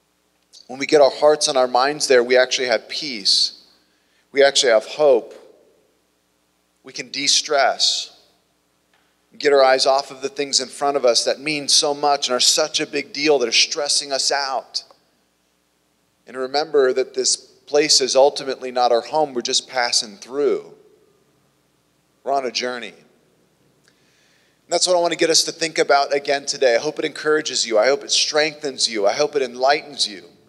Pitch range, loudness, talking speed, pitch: 105-150 Hz, -18 LUFS, 185 wpm, 135 Hz